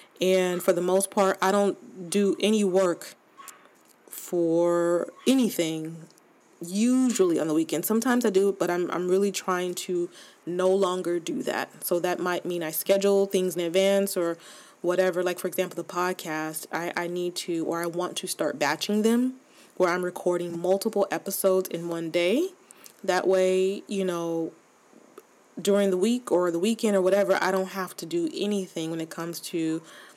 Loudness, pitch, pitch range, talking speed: -26 LUFS, 185 Hz, 175-195 Hz, 170 wpm